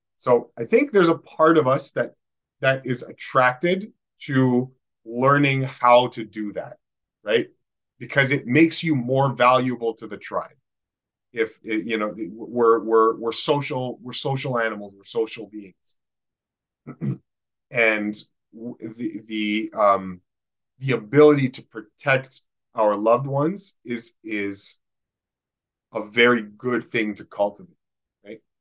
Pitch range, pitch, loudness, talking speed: 110-135 Hz, 120 Hz, -22 LUFS, 125 wpm